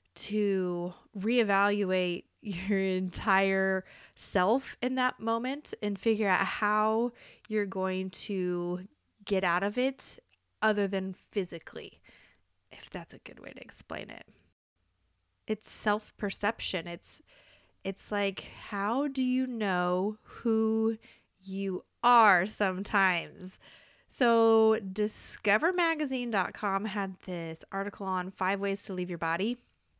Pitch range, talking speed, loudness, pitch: 185-220 Hz, 110 wpm, -30 LUFS, 200 Hz